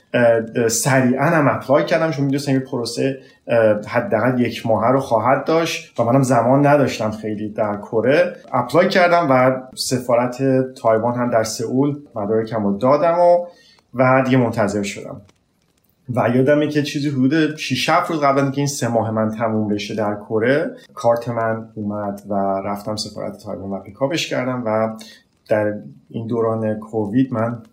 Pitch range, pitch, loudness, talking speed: 110-135 Hz, 120 Hz, -18 LUFS, 150 wpm